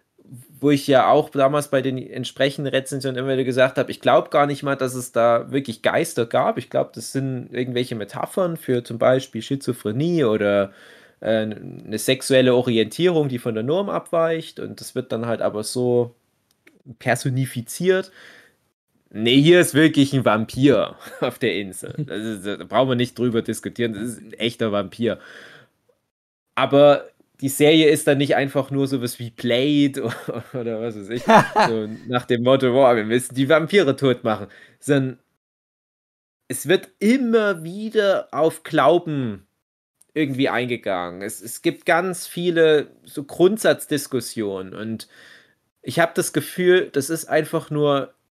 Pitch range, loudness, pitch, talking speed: 115-150 Hz, -20 LUFS, 130 Hz, 155 wpm